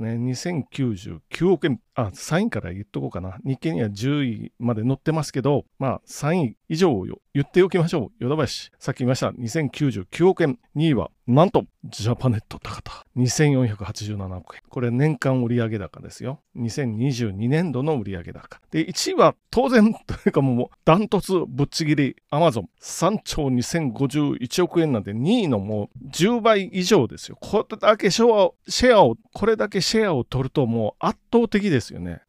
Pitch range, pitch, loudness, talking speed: 120-170 Hz, 135 Hz, -22 LUFS, 295 characters per minute